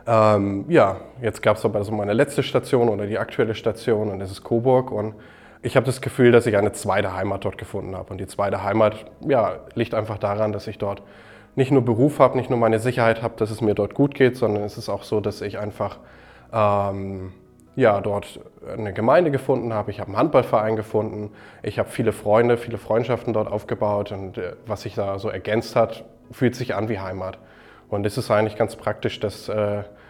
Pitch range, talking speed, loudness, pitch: 100-115 Hz, 210 wpm, -22 LUFS, 110 Hz